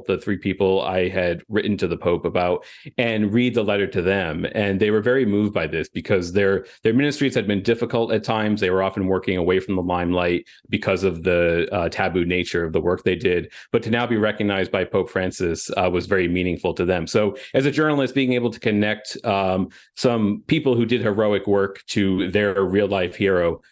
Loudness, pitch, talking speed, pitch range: -21 LUFS, 100 Hz, 215 wpm, 95-115 Hz